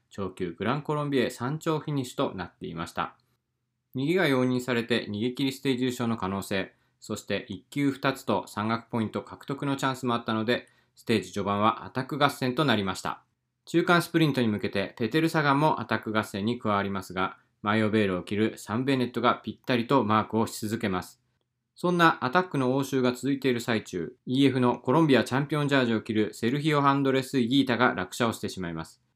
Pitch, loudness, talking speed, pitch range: 120 Hz, -27 LUFS, 440 characters per minute, 110-140 Hz